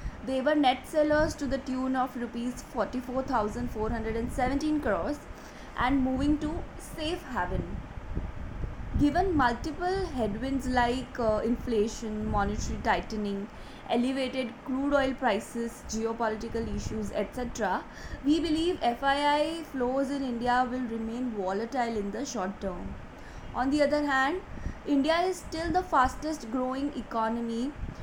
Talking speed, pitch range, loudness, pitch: 120 wpm, 230-285 Hz, -30 LUFS, 255 Hz